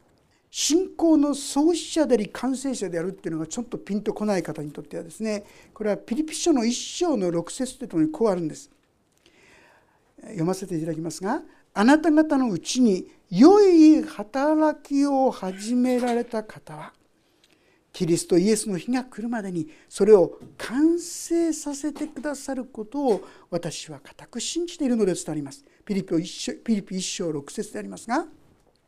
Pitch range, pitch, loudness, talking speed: 180-295 Hz, 235 Hz, -24 LUFS, 300 characters per minute